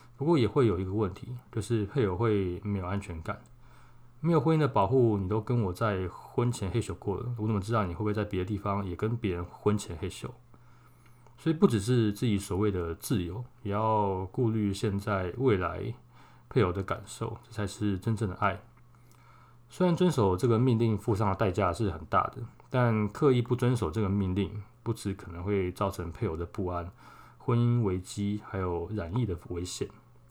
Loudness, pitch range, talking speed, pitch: -30 LUFS, 100-120 Hz, 280 characters per minute, 110 Hz